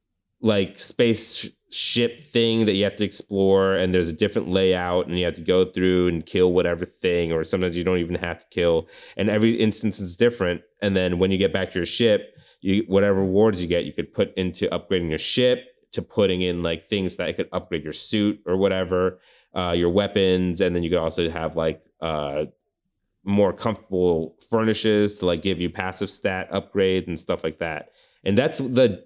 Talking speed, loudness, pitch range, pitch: 200 wpm, -23 LUFS, 85-100 Hz, 95 Hz